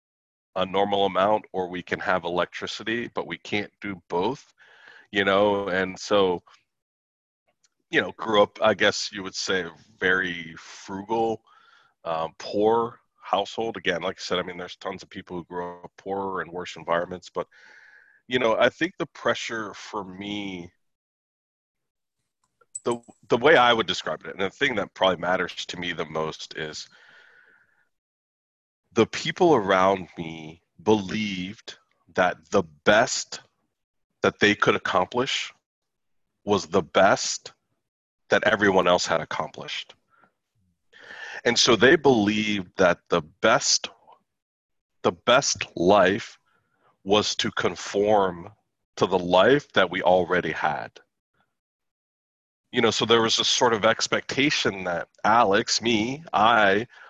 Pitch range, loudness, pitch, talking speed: 90-105 Hz, -23 LUFS, 95 Hz, 135 wpm